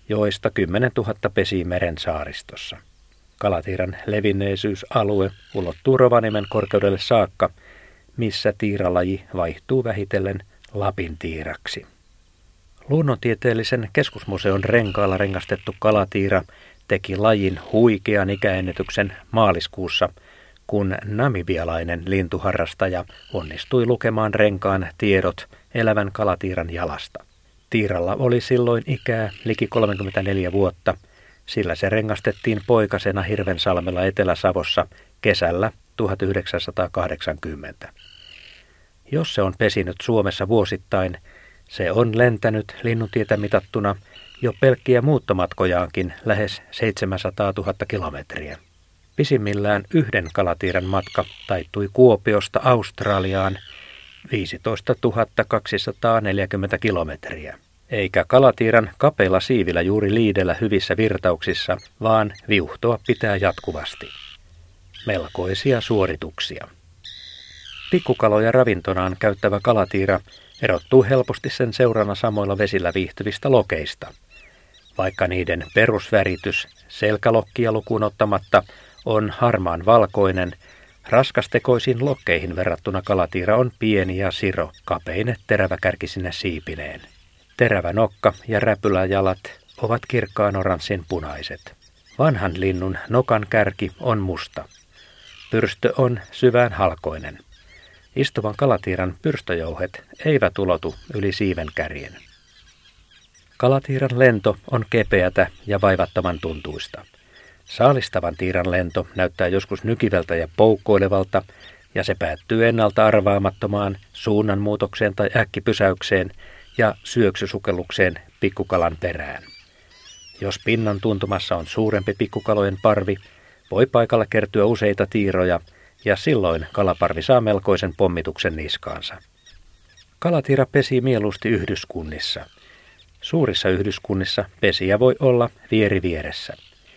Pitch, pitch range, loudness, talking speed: 100 Hz, 90-110 Hz, -21 LUFS, 90 wpm